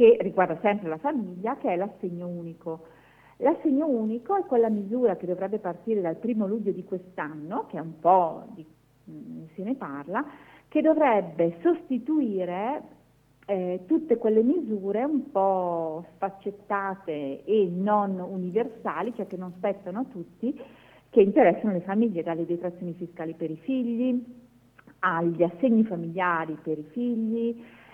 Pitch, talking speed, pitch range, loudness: 195 Hz, 140 wpm, 170-235 Hz, -27 LUFS